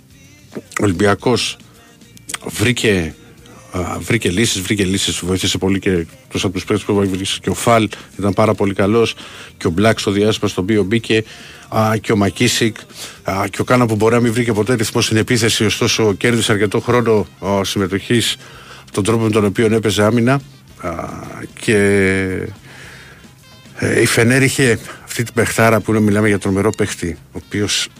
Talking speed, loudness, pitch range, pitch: 160 wpm, -16 LUFS, 100-115 Hz, 110 Hz